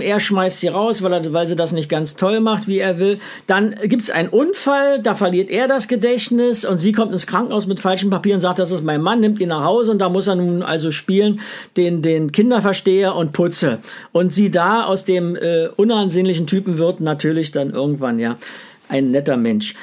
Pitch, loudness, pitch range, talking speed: 190 Hz, -17 LUFS, 170-215 Hz, 220 wpm